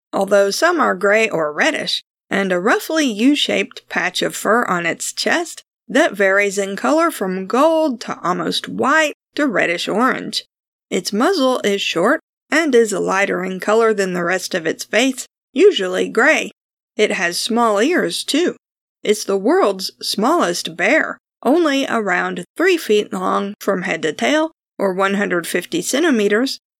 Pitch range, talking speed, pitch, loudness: 200-310 Hz, 150 wpm, 225 Hz, -17 LUFS